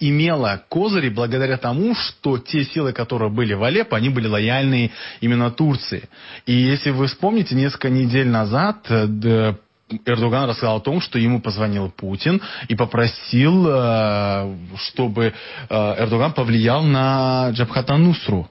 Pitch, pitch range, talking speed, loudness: 120 Hz, 110-135 Hz, 125 wpm, -19 LUFS